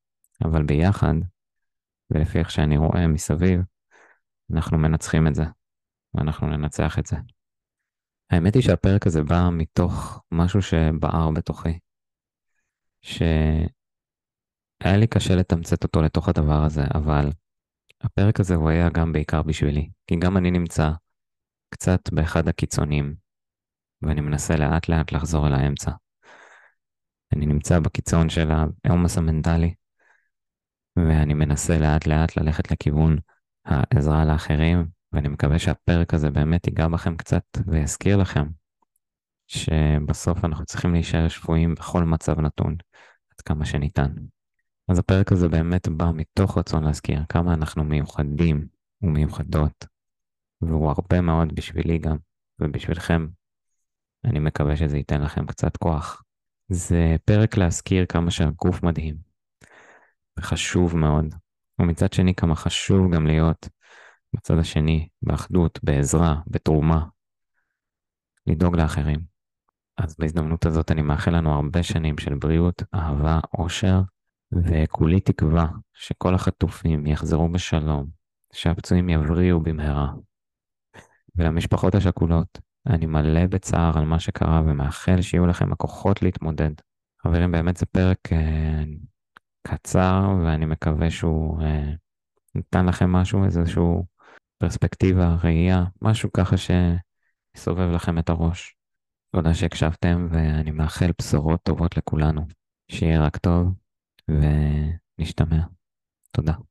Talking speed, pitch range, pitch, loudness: 115 wpm, 75-90 Hz, 80 Hz, -22 LUFS